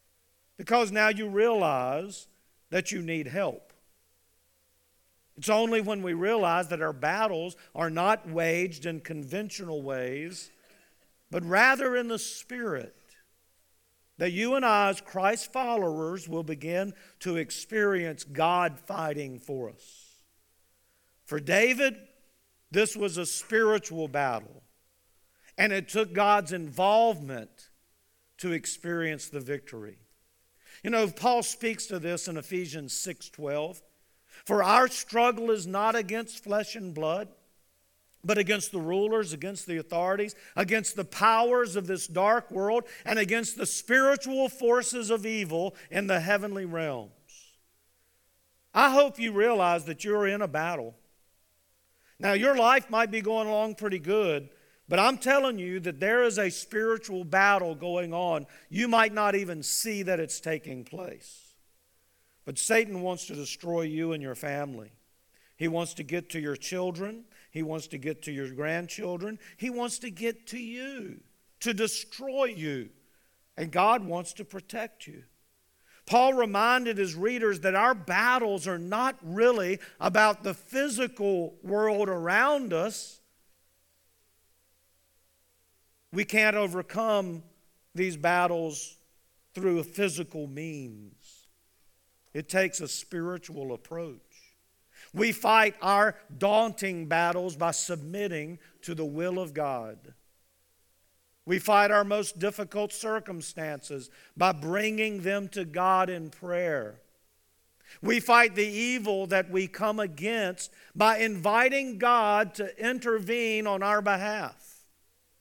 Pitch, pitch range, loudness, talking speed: 185 Hz, 155-215 Hz, -28 LUFS, 130 wpm